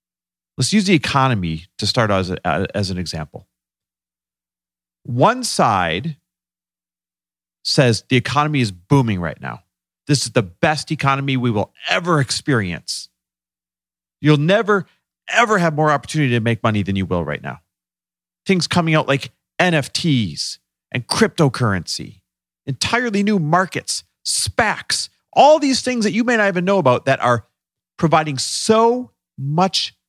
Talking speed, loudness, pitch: 140 wpm, -18 LUFS, 120 Hz